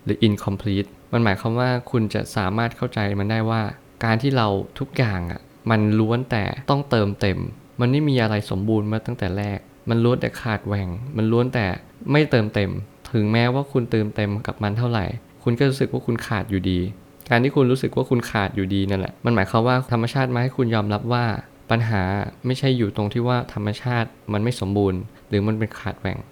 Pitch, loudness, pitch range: 115 Hz, -22 LUFS, 100-125 Hz